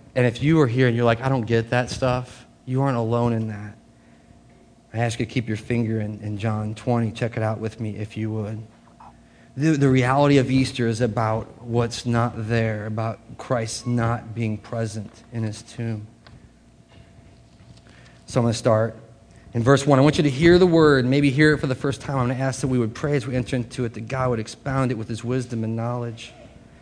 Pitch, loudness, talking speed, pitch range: 120 Hz, -22 LUFS, 225 wpm, 110-130 Hz